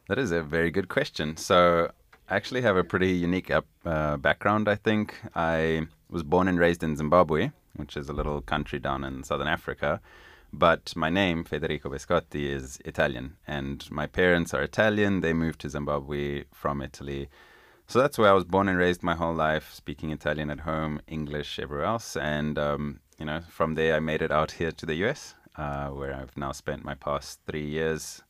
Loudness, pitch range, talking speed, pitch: -27 LUFS, 75-85 Hz, 195 wpm, 80 Hz